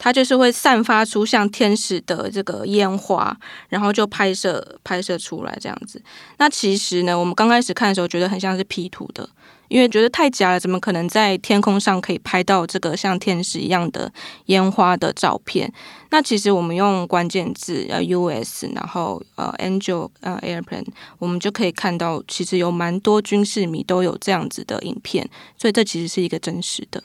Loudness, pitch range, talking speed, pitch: -19 LUFS, 180-210 Hz, 315 characters per minute, 190 Hz